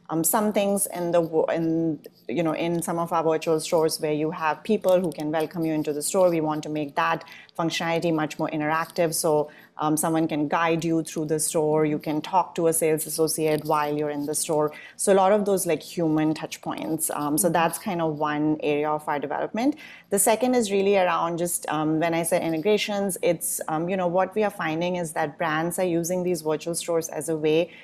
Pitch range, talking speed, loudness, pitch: 155-175 Hz, 225 wpm, -24 LUFS, 165 Hz